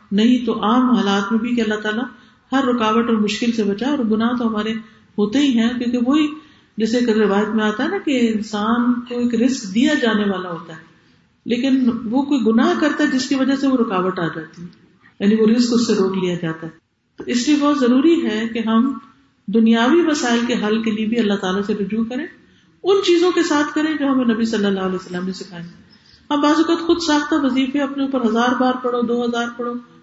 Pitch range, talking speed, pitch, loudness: 215-265 Hz, 225 wpm, 235 Hz, -18 LUFS